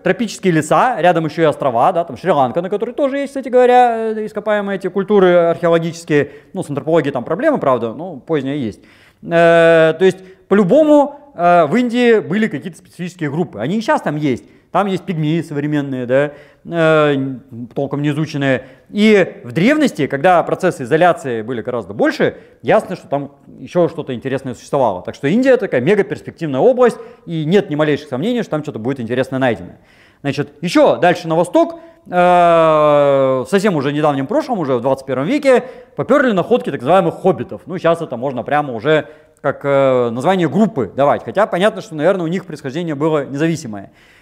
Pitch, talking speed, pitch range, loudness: 165 Hz, 165 wpm, 140-195 Hz, -15 LUFS